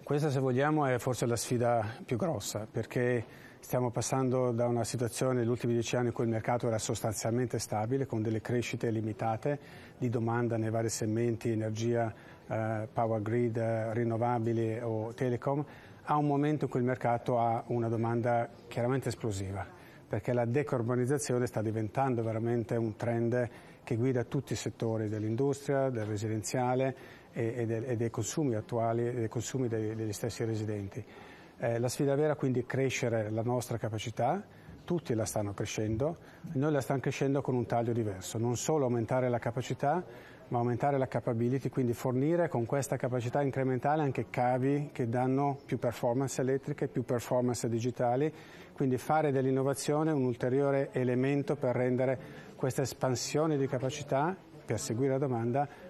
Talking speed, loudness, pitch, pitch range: 155 wpm, -32 LUFS, 125 Hz, 115-135 Hz